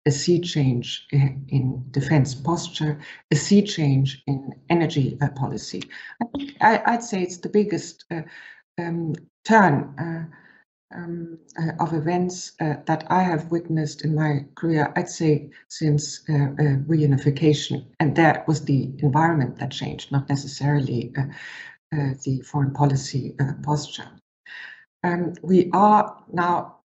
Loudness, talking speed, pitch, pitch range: -23 LUFS, 140 wpm, 155 Hz, 140-170 Hz